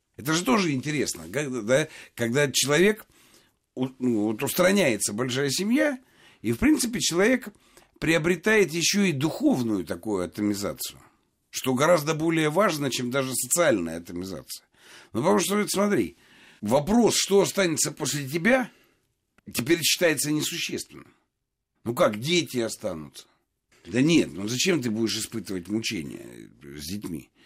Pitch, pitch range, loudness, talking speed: 150 Hz, 120-185 Hz, -24 LUFS, 125 wpm